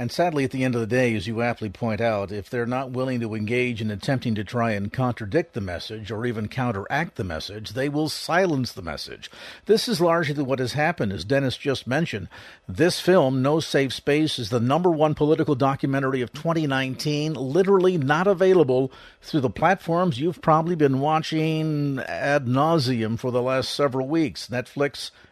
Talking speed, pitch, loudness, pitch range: 185 wpm, 135 Hz, -23 LUFS, 120-155 Hz